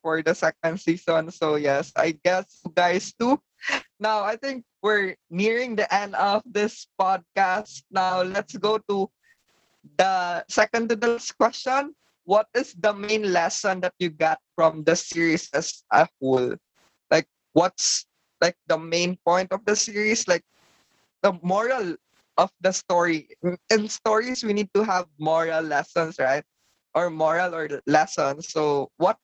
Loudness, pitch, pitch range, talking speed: -24 LUFS, 185 Hz, 165-210 Hz, 155 wpm